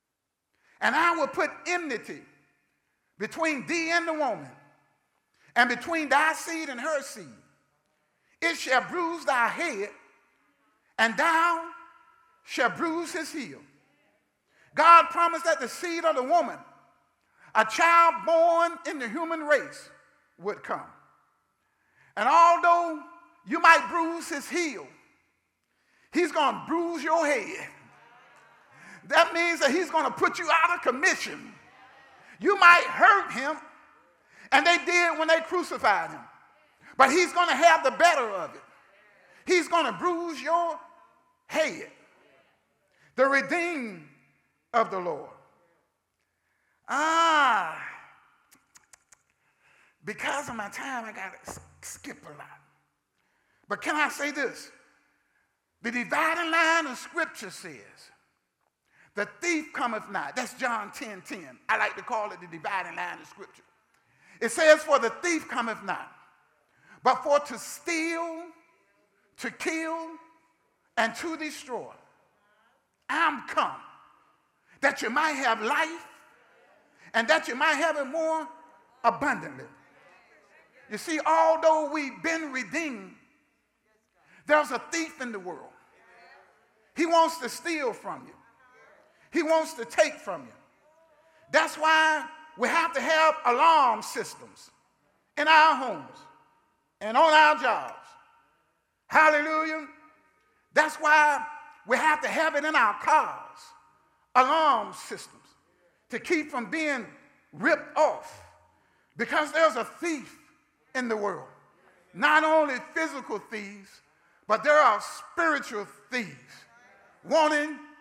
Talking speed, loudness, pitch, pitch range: 125 wpm, -25 LUFS, 315 Hz, 280-335 Hz